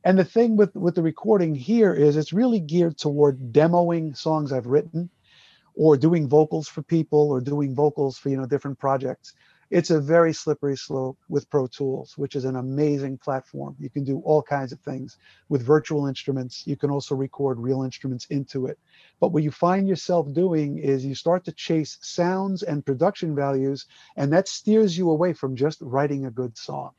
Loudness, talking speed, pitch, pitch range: -23 LUFS, 195 wpm, 145 Hz, 135-170 Hz